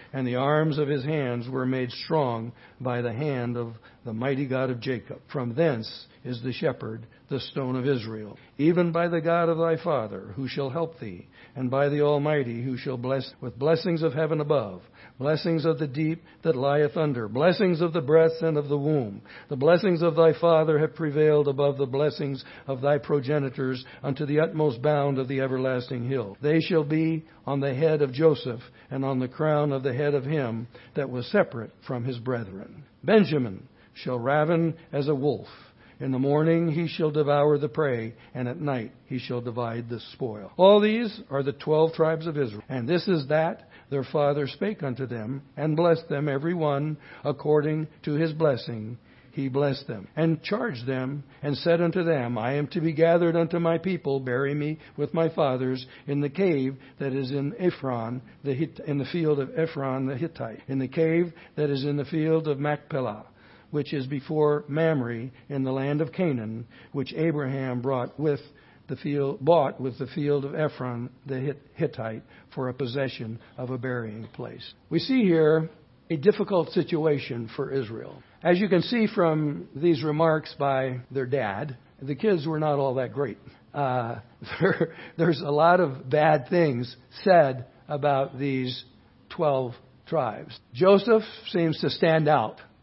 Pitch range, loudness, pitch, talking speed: 130-160 Hz, -26 LUFS, 145 Hz, 180 wpm